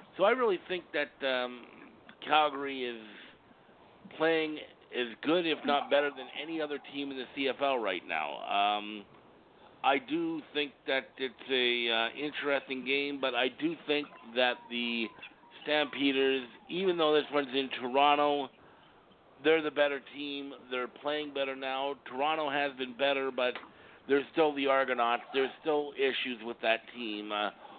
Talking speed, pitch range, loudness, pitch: 150 wpm, 125-145 Hz, -31 LUFS, 140 Hz